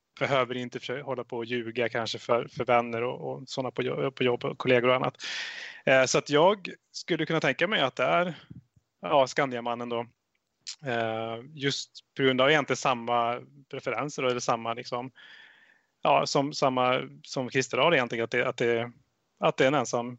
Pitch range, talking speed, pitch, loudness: 120-135 Hz, 180 wpm, 125 Hz, -27 LUFS